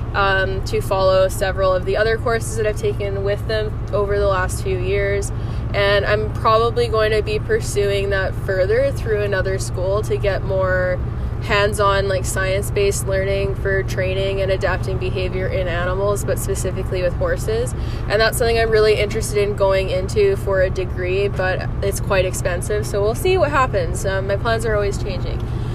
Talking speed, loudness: 180 wpm, -19 LUFS